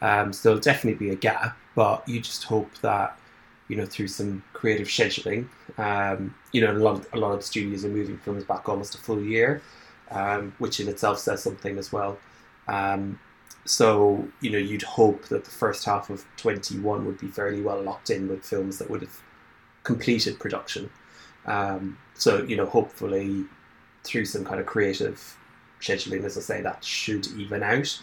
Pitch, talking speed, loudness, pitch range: 100 Hz, 185 wpm, -26 LUFS, 95-105 Hz